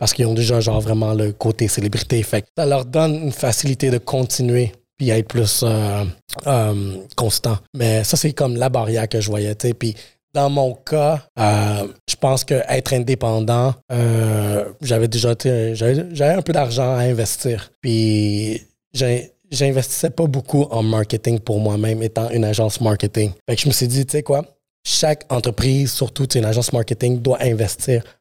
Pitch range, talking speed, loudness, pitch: 110-135 Hz, 160 wpm, -19 LUFS, 120 Hz